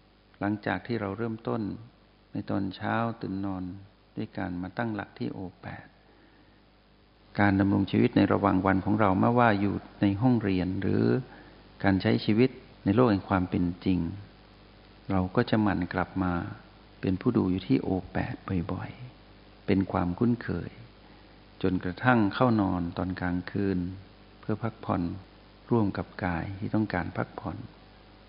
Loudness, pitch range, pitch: -28 LUFS, 95-110 Hz, 100 Hz